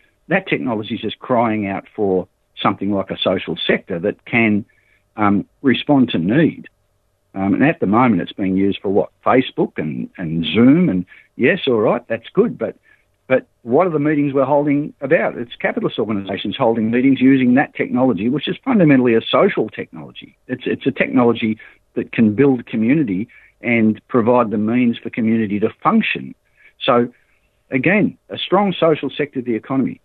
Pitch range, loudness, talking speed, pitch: 100-135 Hz, -17 LUFS, 170 wpm, 115 Hz